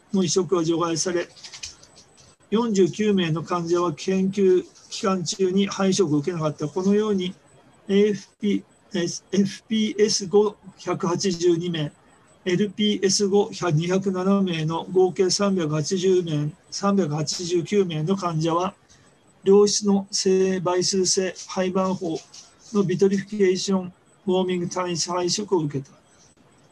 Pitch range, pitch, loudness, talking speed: 175-195 Hz, 185 Hz, -23 LUFS, 190 characters per minute